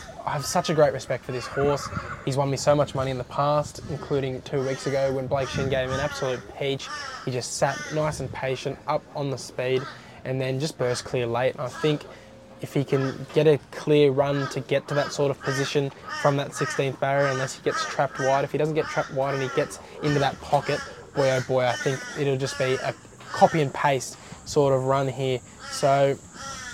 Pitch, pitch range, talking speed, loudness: 140 Hz, 130-145 Hz, 225 wpm, -25 LUFS